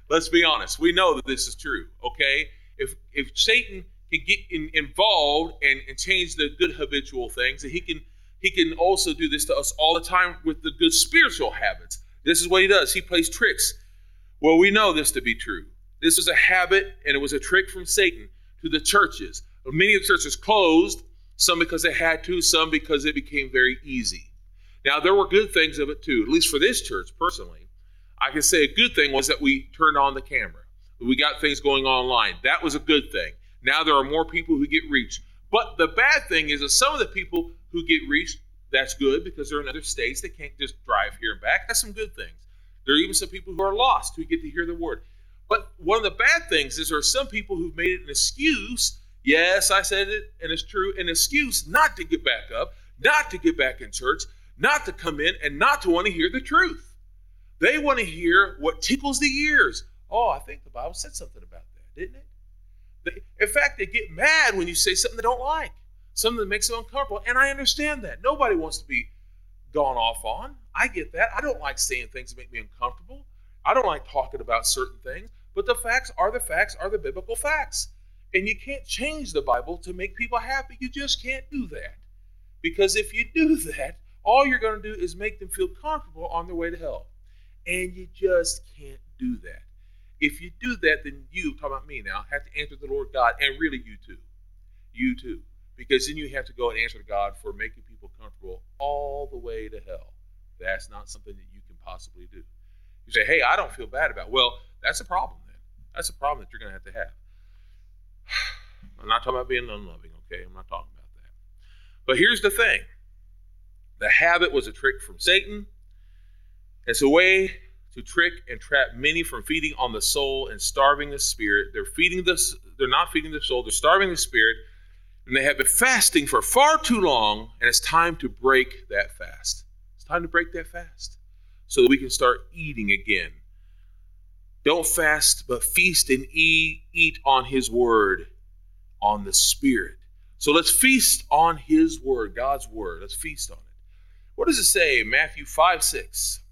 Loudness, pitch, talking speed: -22 LUFS, 160 Hz, 215 wpm